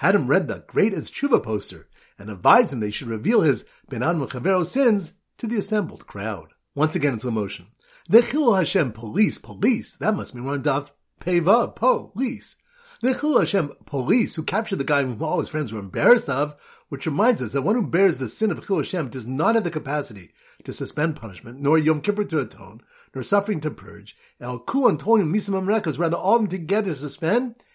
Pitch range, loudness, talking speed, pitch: 130-210 Hz, -23 LUFS, 200 wpm, 160 Hz